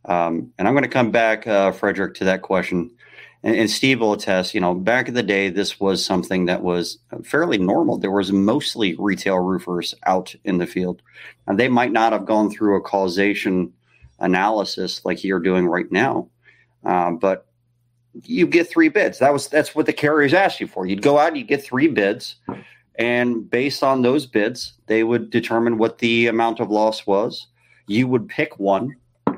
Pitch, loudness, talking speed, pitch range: 110 Hz, -19 LUFS, 195 wpm, 95-120 Hz